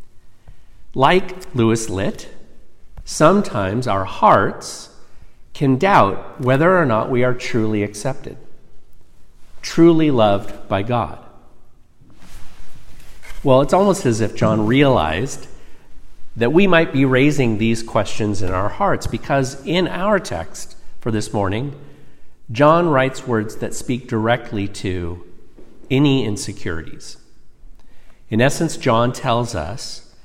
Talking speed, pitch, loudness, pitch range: 115 wpm, 120 Hz, -18 LUFS, 110-140 Hz